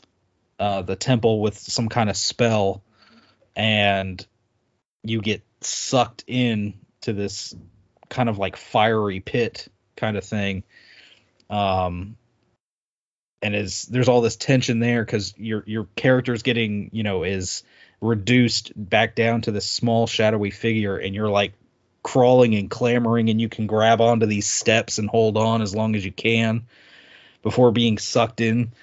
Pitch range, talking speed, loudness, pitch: 100-115 Hz, 150 wpm, -21 LUFS, 110 Hz